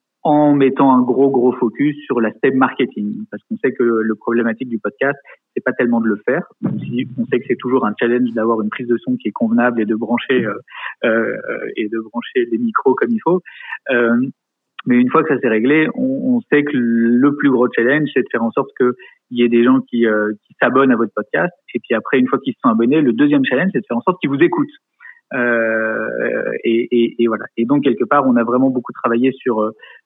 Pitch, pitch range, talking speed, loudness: 125 Hz, 115-145 Hz, 245 wpm, -16 LUFS